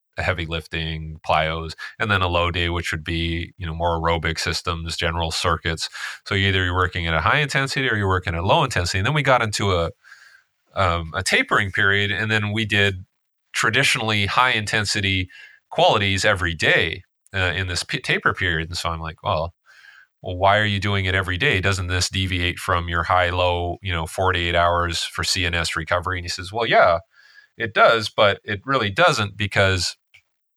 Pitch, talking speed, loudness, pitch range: 95 Hz, 195 wpm, -20 LUFS, 85-105 Hz